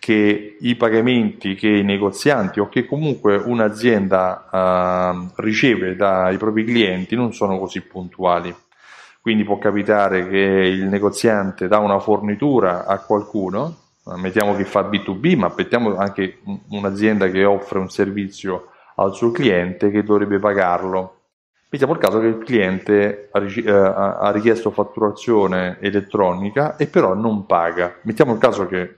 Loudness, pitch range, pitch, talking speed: -18 LUFS, 95-110 Hz, 100 Hz, 135 wpm